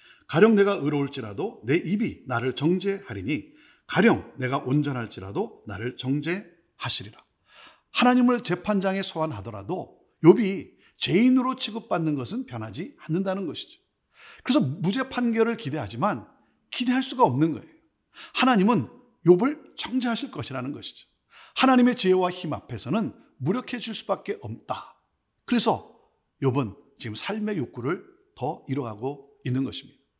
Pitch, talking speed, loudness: 180 Hz, 315 characters per minute, -26 LUFS